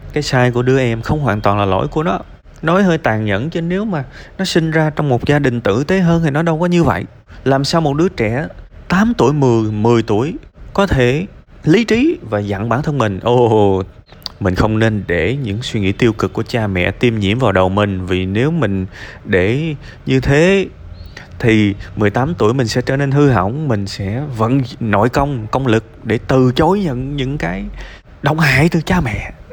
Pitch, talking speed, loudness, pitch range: 125 Hz, 215 wpm, -15 LUFS, 105-150 Hz